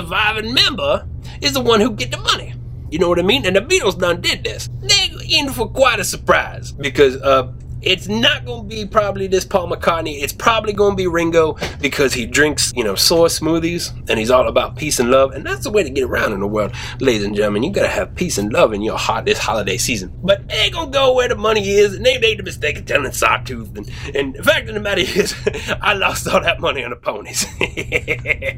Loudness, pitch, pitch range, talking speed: -16 LUFS, 155 Hz, 120-195 Hz, 235 wpm